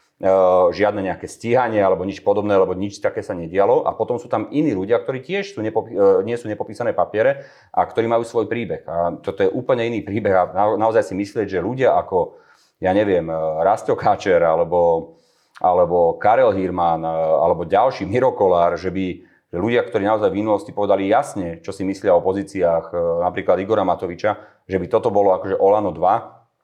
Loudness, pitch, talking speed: -19 LUFS, 100 Hz, 175 wpm